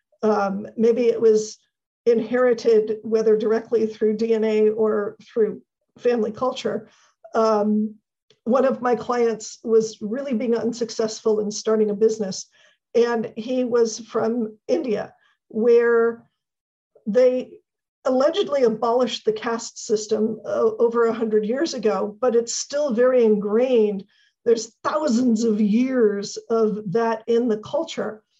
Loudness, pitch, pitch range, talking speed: -21 LUFS, 225 Hz, 215-240 Hz, 120 wpm